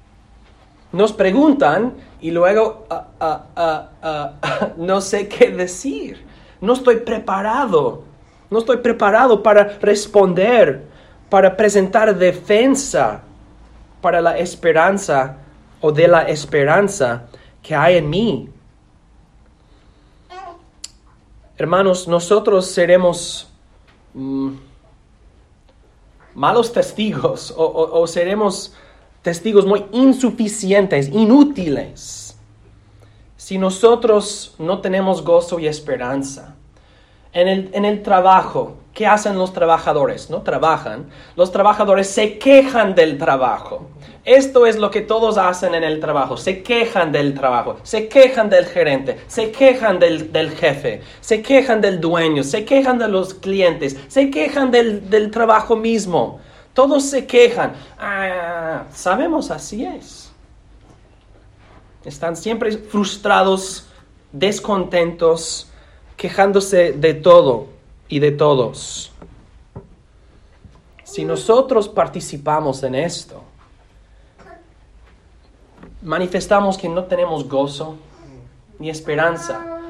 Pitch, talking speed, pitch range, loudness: 180 Hz, 105 wpm, 150-215 Hz, -16 LUFS